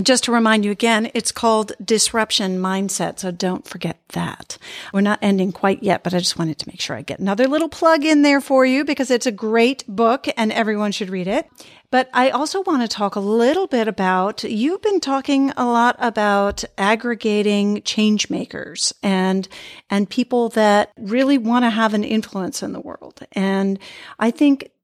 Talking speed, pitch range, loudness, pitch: 190 wpm, 200-255 Hz, -19 LUFS, 220 Hz